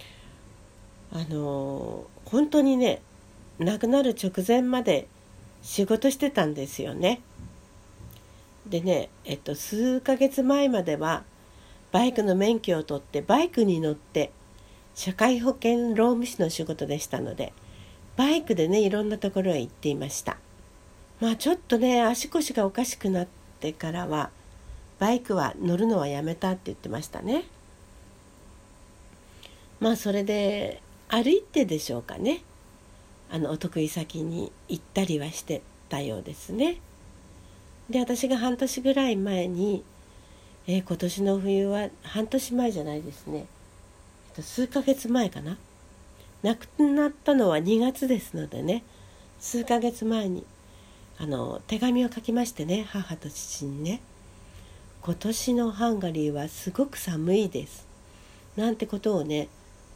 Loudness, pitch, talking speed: -27 LUFS, 185 Hz, 255 characters per minute